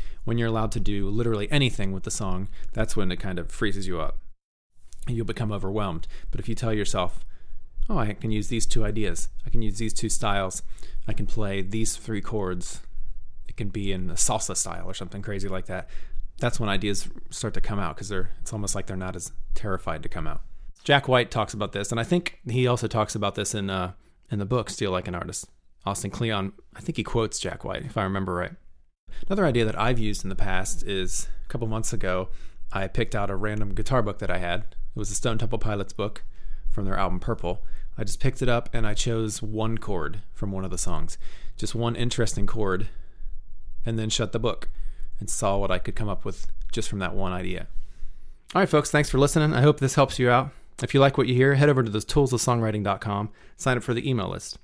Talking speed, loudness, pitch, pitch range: 230 wpm, -27 LUFS, 105 Hz, 95-115 Hz